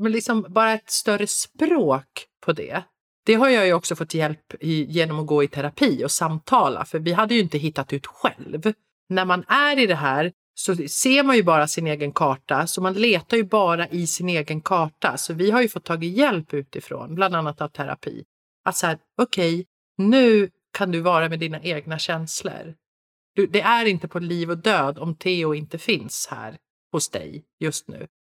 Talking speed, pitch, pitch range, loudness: 200 wpm, 175 Hz, 160-215 Hz, -22 LUFS